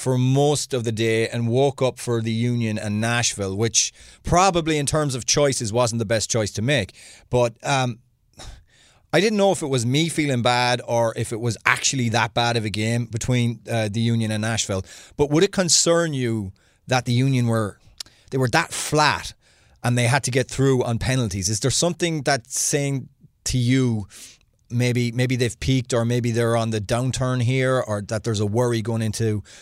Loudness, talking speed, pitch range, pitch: -21 LUFS, 200 wpm, 115-130 Hz, 120 Hz